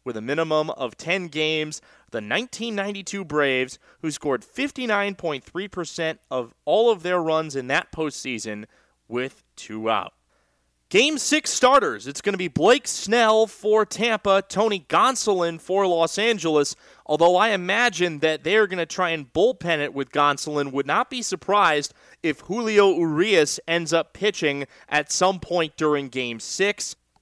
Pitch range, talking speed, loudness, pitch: 145-200 Hz, 150 wpm, -22 LUFS, 170 Hz